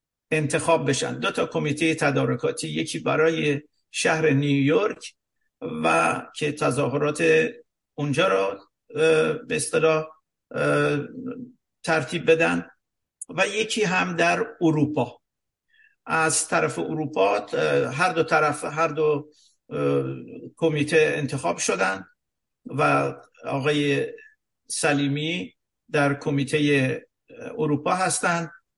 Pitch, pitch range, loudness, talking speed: 155 Hz, 145-170 Hz, -23 LUFS, 85 wpm